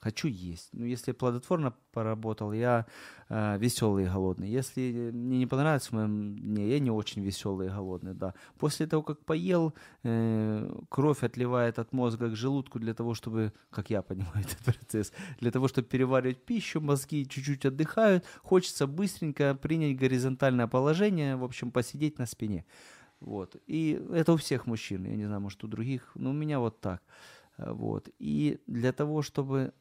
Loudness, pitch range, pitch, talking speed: -31 LUFS, 110-145 Hz, 125 Hz, 170 wpm